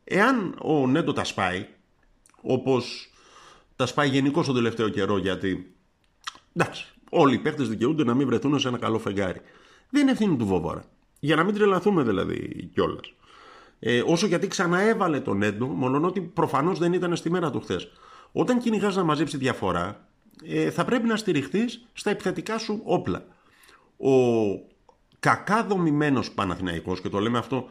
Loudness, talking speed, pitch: -25 LUFS, 160 wpm, 145 Hz